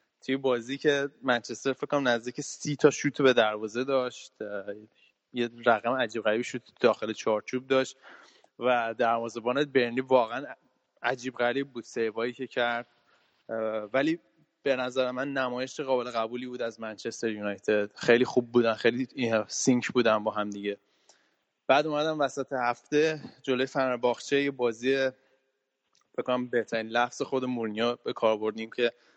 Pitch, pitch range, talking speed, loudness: 125 Hz, 115-130 Hz, 140 wpm, -28 LUFS